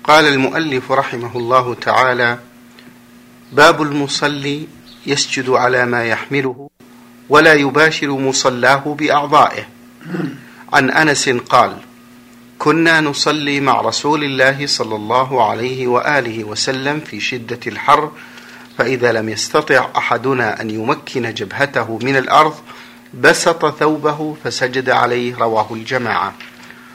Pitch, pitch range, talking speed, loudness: 130 Hz, 120-145 Hz, 100 wpm, -14 LUFS